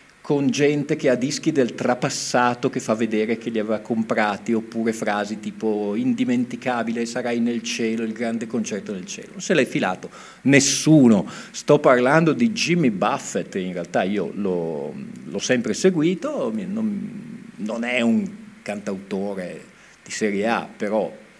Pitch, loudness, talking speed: 130 Hz, -22 LUFS, 145 wpm